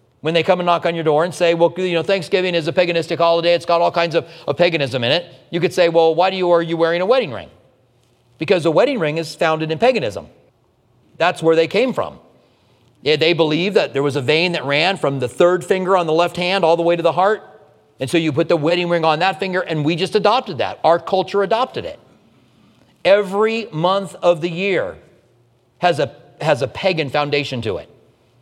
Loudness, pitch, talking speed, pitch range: -17 LUFS, 170 Hz, 230 wpm, 160-185 Hz